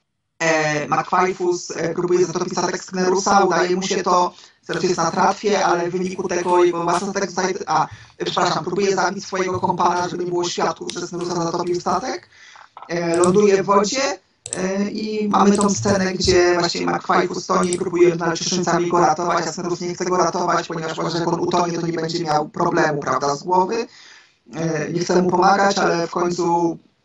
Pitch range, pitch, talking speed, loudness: 170-185 Hz, 180 Hz, 175 wpm, -19 LUFS